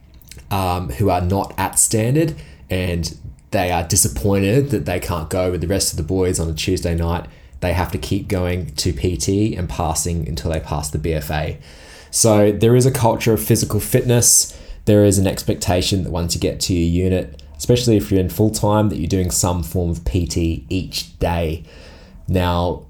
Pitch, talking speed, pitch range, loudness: 90 Hz, 190 wpm, 85-105 Hz, -18 LUFS